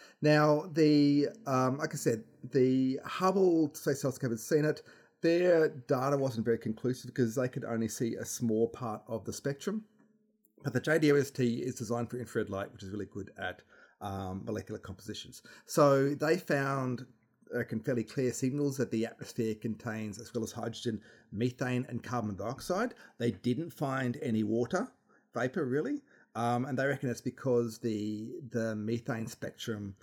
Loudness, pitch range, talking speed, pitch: -32 LUFS, 115-145 Hz, 160 wpm, 125 Hz